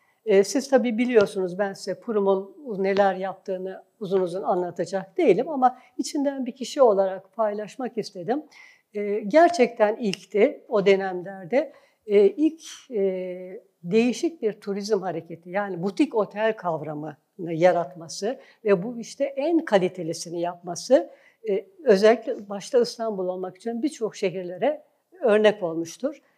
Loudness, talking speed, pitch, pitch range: -24 LUFS, 110 wpm, 210 Hz, 190-260 Hz